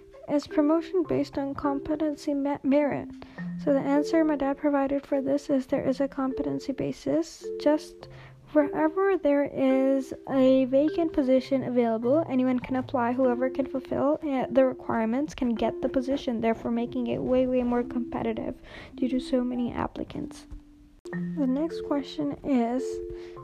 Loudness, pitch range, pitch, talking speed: -27 LUFS, 255-295 Hz, 275 Hz, 145 wpm